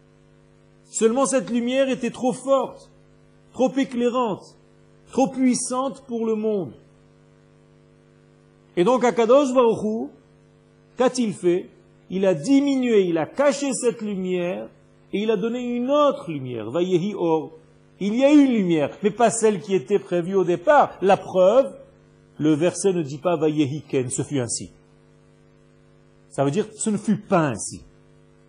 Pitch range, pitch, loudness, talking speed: 175-250 Hz, 210 Hz, -22 LUFS, 145 wpm